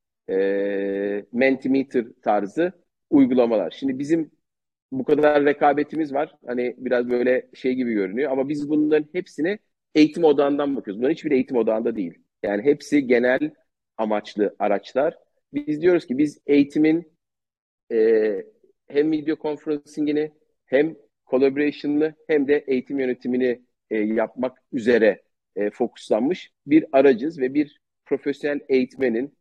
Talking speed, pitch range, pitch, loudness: 120 wpm, 125-155 Hz, 145 Hz, -22 LUFS